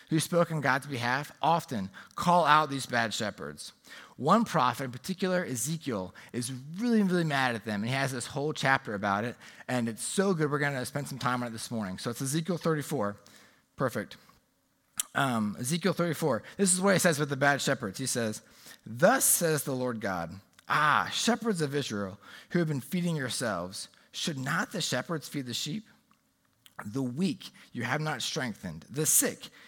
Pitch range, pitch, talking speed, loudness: 120-165 Hz, 140 Hz, 185 wpm, -29 LUFS